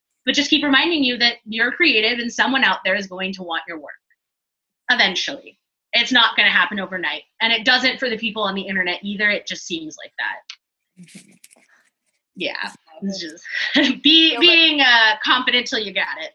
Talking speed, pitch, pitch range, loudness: 185 wpm, 230 Hz, 195-265 Hz, -17 LUFS